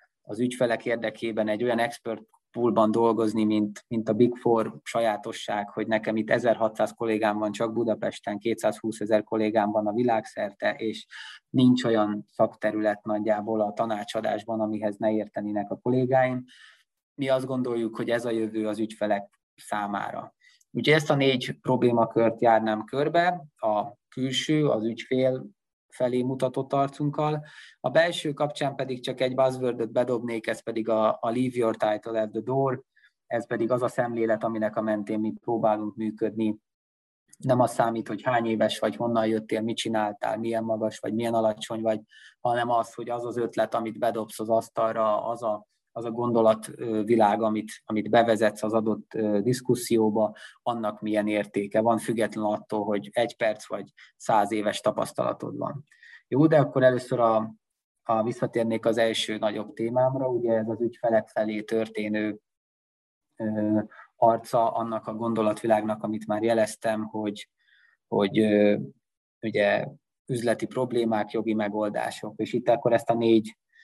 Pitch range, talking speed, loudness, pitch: 110-120 Hz, 145 wpm, -26 LUFS, 110 Hz